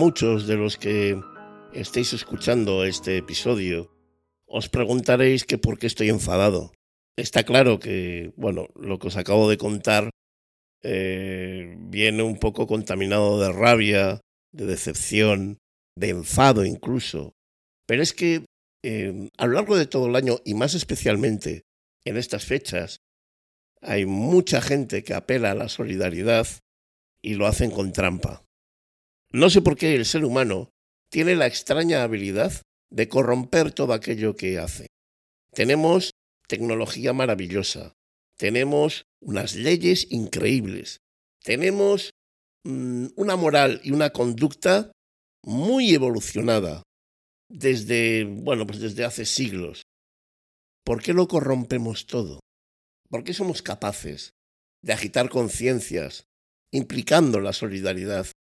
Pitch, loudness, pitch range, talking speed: 110 Hz, -23 LUFS, 95-130 Hz, 125 wpm